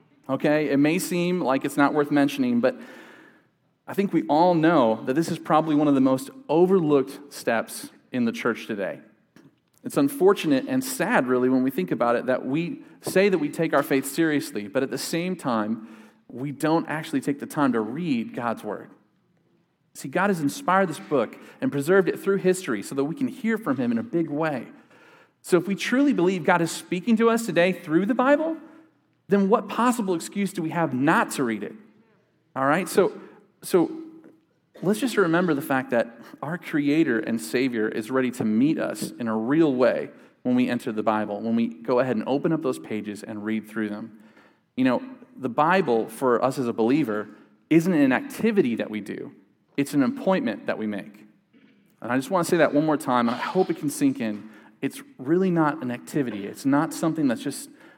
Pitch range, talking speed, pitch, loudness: 130-215 Hz, 205 wpm, 160 Hz, -24 LUFS